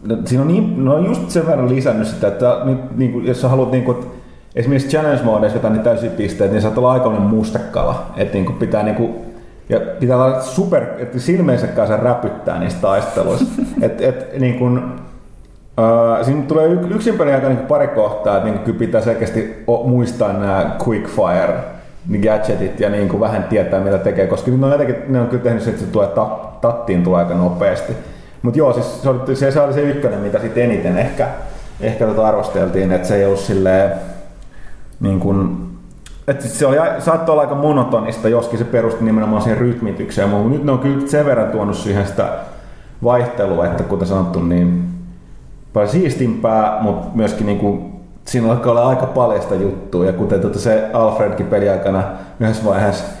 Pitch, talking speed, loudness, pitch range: 115 Hz, 180 wpm, -16 LUFS, 100-130 Hz